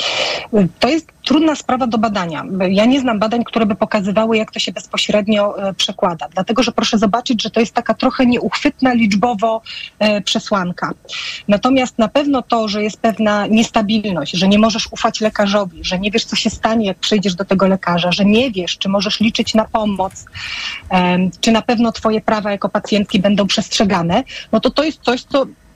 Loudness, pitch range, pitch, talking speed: -16 LUFS, 205-235 Hz, 220 Hz, 180 wpm